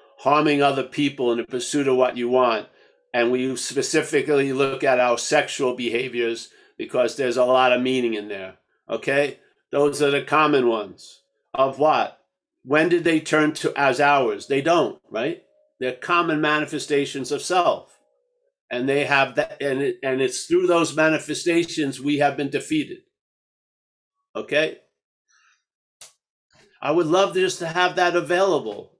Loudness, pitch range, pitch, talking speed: -21 LUFS, 130-165 Hz, 145 Hz, 155 wpm